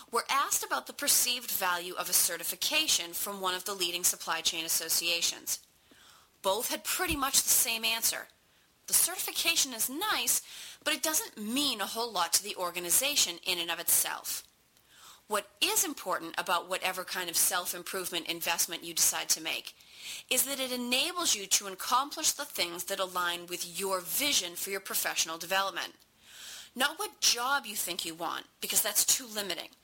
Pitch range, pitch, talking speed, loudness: 175-265 Hz, 195 Hz, 170 wpm, -29 LUFS